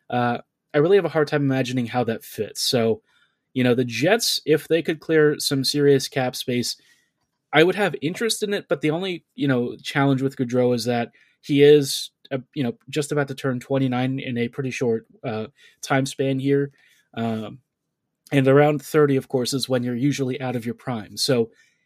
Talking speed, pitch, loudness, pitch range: 200 wpm, 135 Hz, -22 LUFS, 125-150 Hz